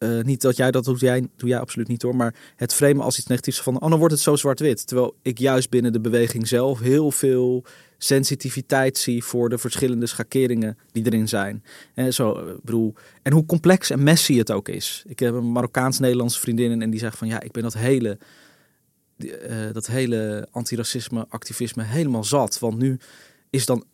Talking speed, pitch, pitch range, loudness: 195 wpm, 125 Hz, 115-135 Hz, -21 LUFS